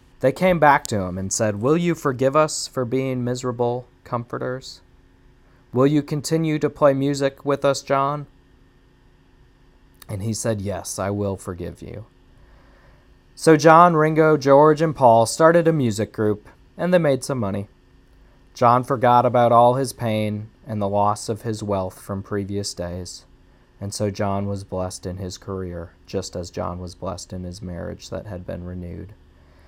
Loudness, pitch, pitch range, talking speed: -20 LUFS, 110 Hz, 95-135 Hz, 165 wpm